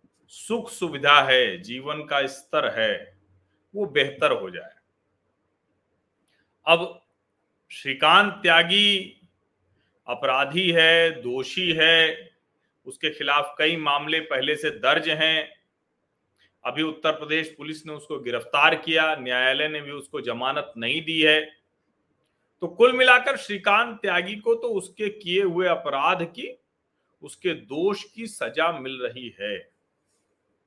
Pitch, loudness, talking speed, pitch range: 160 Hz, -22 LUFS, 120 wpm, 145-195 Hz